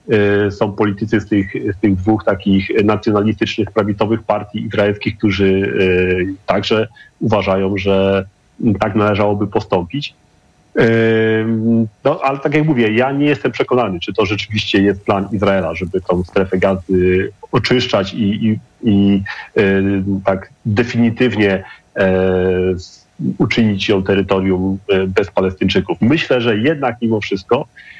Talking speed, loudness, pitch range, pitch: 115 wpm, -16 LUFS, 95-110 Hz, 105 Hz